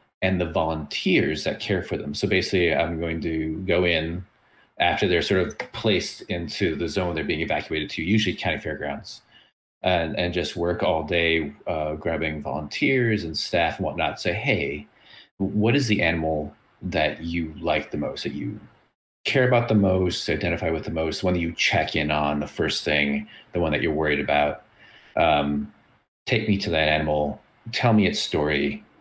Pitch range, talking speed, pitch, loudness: 75-100 Hz, 180 wpm, 85 Hz, -24 LUFS